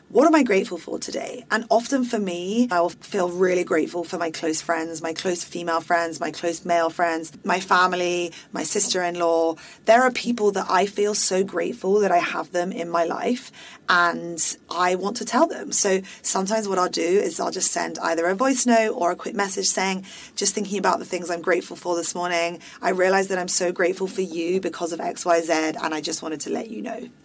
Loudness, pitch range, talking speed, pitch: -22 LUFS, 170-200 Hz, 215 wpm, 180 Hz